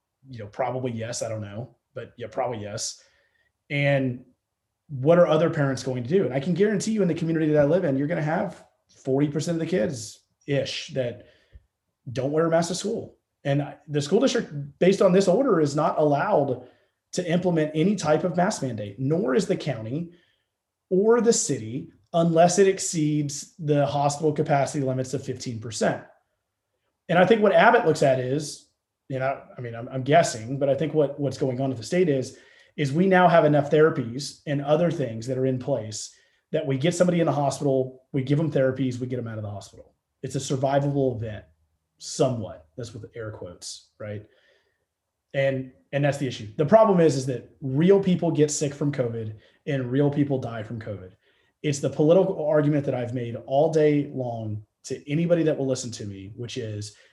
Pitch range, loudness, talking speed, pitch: 125-160 Hz, -24 LUFS, 200 wpm, 140 Hz